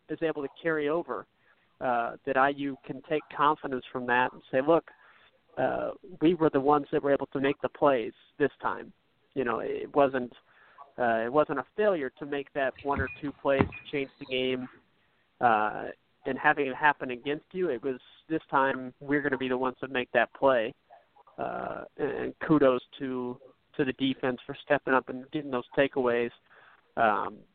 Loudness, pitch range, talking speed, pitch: -29 LUFS, 130-150 Hz, 190 wpm, 140 Hz